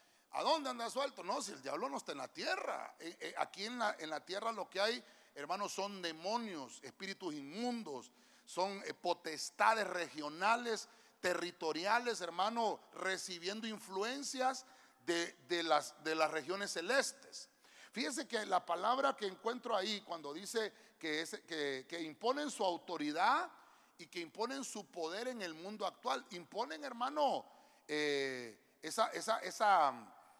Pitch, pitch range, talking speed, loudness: 200 Hz, 170-240 Hz, 140 wpm, -39 LUFS